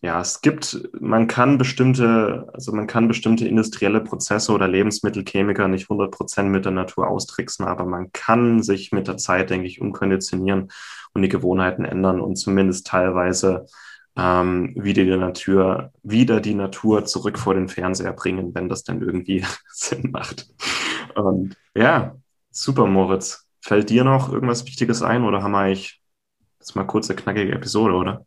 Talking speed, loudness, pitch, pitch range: 160 wpm, -20 LUFS, 95 Hz, 95-110 Hz